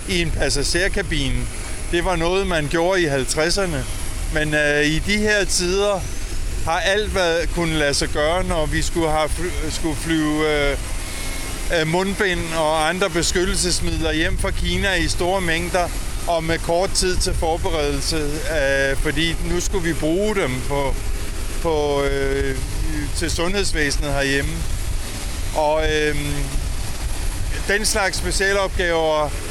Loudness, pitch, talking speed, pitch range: -21 LUFS, 155 Hz, 125 wpm, 130-175 Hz